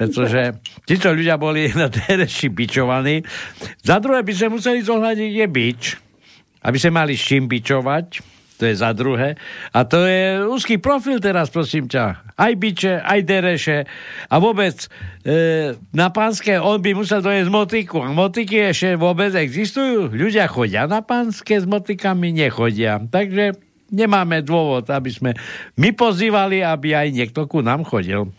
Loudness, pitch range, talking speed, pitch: -18 LUFS, 130-205 Hz, 150 wpm, 170 Hz